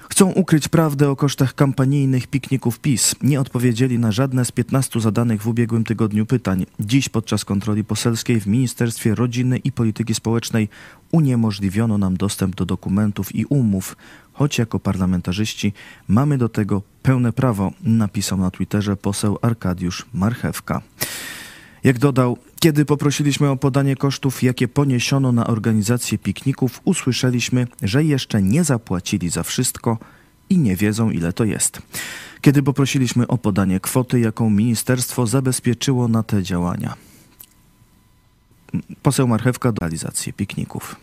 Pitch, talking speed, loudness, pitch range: 120 Hz, 135 wpm, -19 LUFS, 105-135 Hz